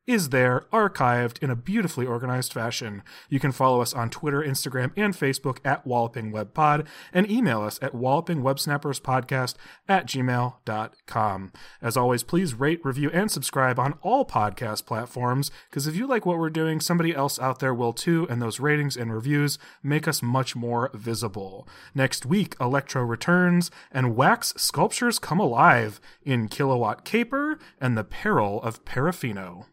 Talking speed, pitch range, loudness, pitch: 155 wpm, 120-160 Hz, -25 LUFS, 135 Hz